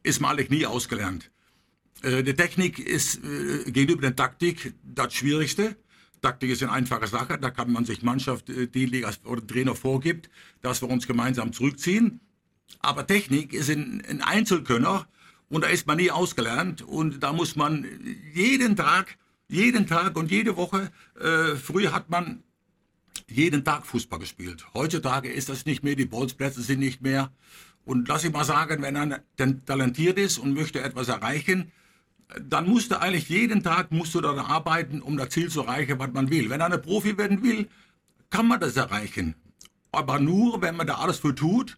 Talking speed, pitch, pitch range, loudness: 175 wpm, 150 Hz, 130-180 Hz, -25 LUFS